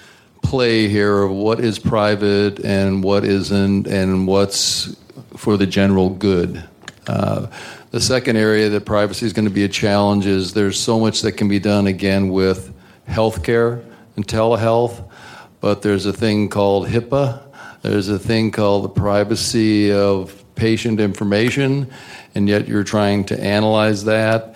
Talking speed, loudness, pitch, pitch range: 150 wpm, -17 LUFS, 105 Hz, 100-110 Hz